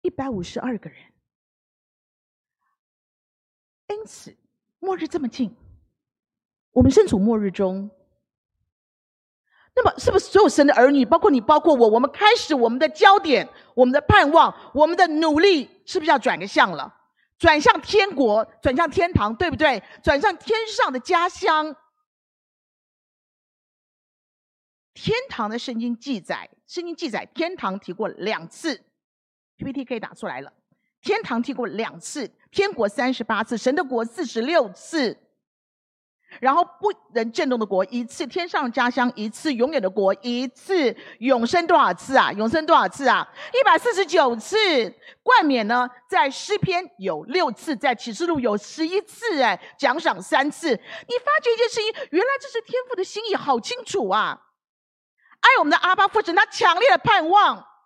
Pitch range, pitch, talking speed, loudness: 235-375 Hz, 300 Hz, 230 characters per minute, -20 LUFS